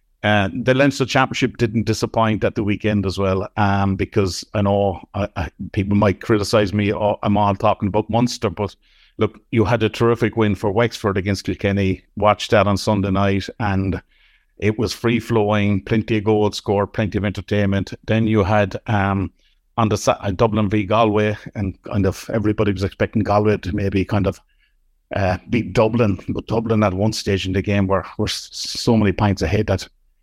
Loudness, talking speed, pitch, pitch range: -19 LUFS, 185 wpm, 105 Hz, 100-110 Hz